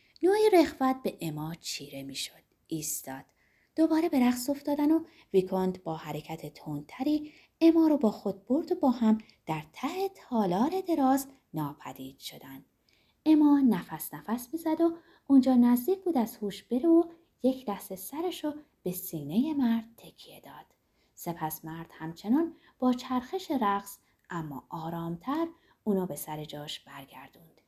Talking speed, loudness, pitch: 140 wpm, -29 LUFS, 240 Hz